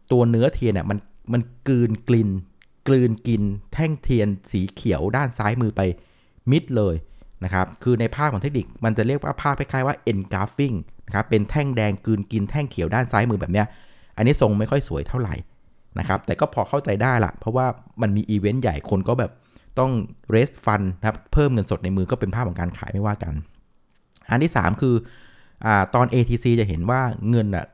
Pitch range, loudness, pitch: 100-125 Hz, -22 LUFS, 110 Hz